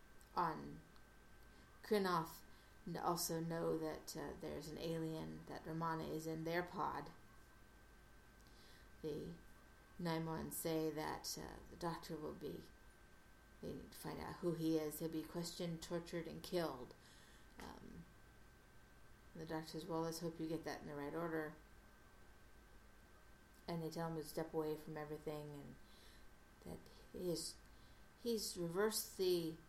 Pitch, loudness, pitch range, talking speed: 160 Hz, -45 LUFS, 155-170 Hz, 140 wpm